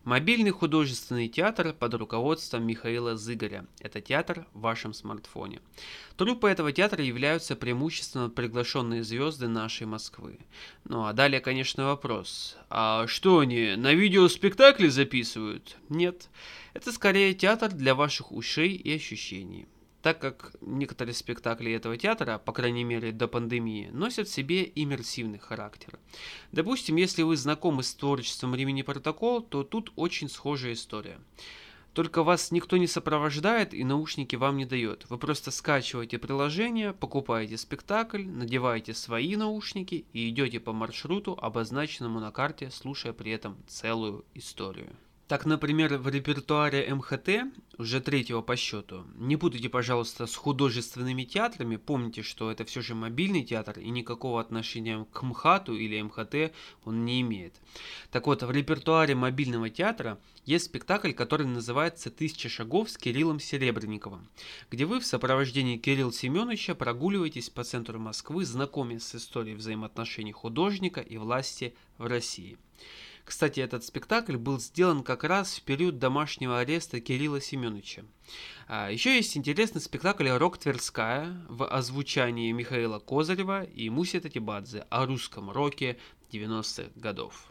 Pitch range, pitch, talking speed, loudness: 115-160 Hz, 130 Hz, 135 wpm, -29 LUFS